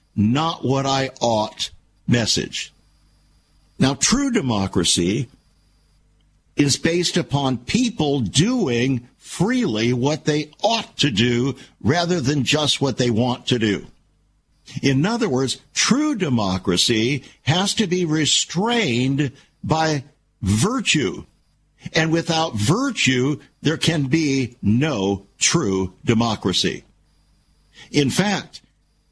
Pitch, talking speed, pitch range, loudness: 135 Hz, 100 wpm, 120-160 Hz, -20 LUFS